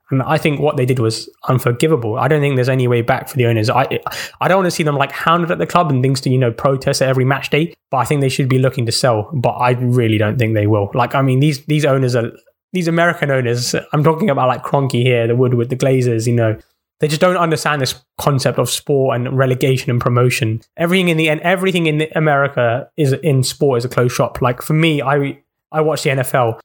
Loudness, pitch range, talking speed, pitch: -16 LUFS, 120-150 Hz, 255 wpm, 135 Hz